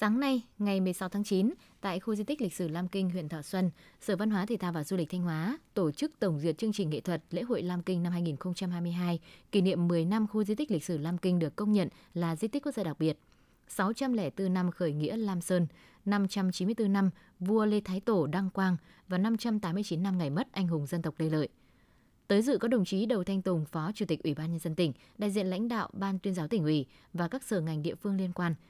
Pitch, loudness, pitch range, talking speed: 185 Hz, -32 LUFS, 170-210 Hz, 250 wpm